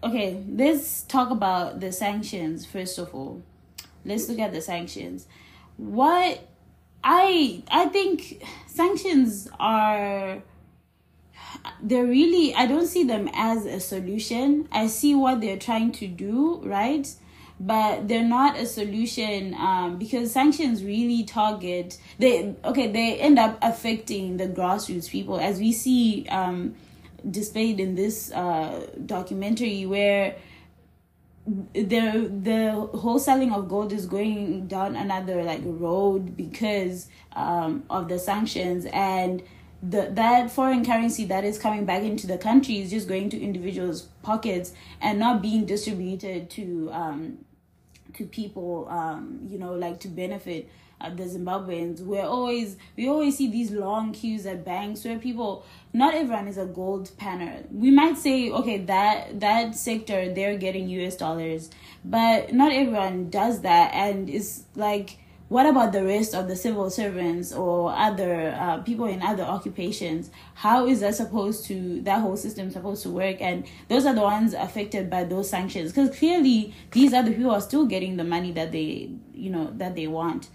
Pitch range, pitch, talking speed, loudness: 185-235 Hz, 205 Hz, 155 wpm, -25 LUFS